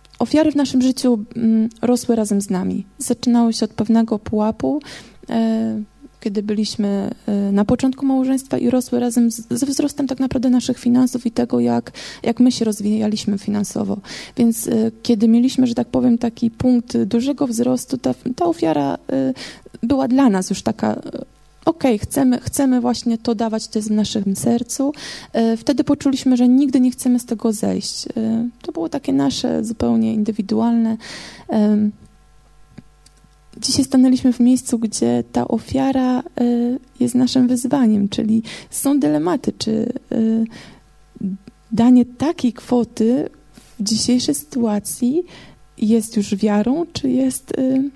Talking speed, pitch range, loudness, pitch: 140 wpm, 225-260 Hz, -18 LUFS, 240 Hz